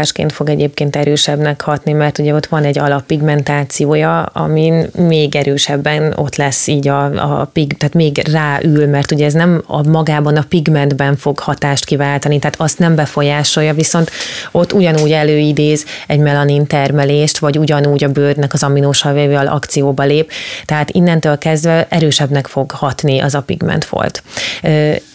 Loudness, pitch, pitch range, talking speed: -12 LUFS, 150 Hz, 145-155 Hz, 150 wpm